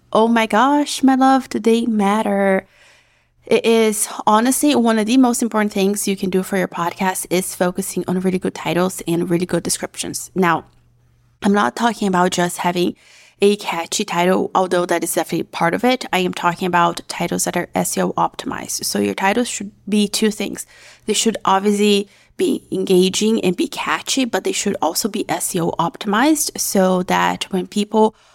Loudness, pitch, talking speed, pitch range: -18 LUFS, 195 Hz, 180 wpm, 180-220 Hz